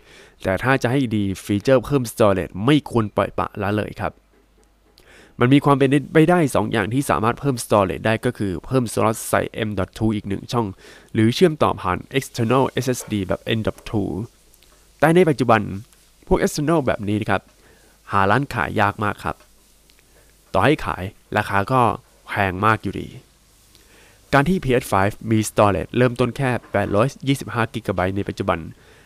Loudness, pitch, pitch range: -20 LUFS, 110 Hz, 100-130 Hz